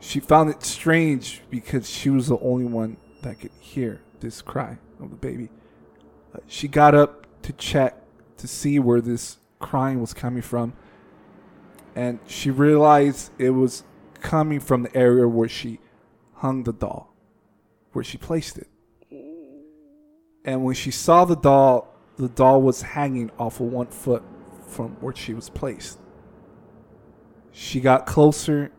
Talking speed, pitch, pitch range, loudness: 150 wpm, 130 Hz, 120-145 Hz, -21 LUFS